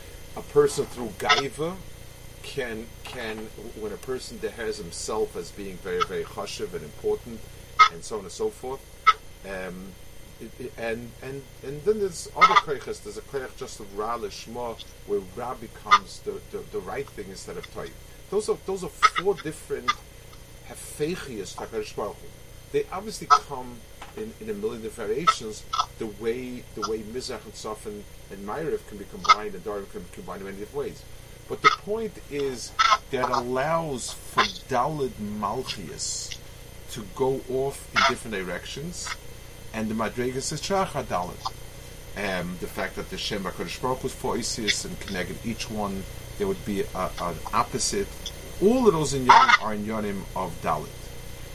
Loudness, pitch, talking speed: -27 LUFS, 140 Hz, 160 wpm